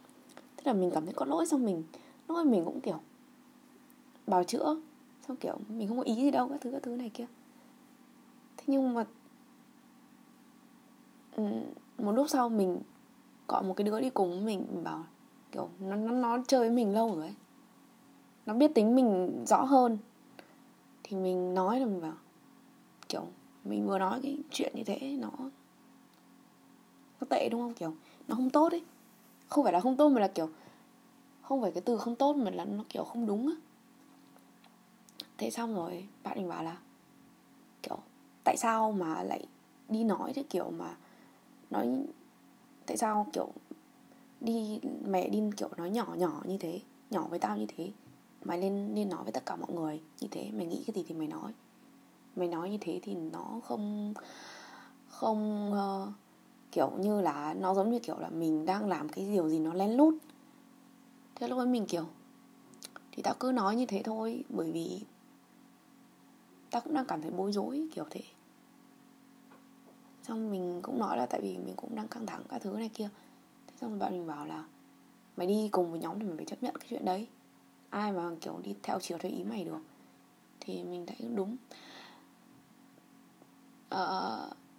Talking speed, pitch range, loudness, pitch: 180 wpm, 195-265 Hz, -34 LUFS, 240 Hz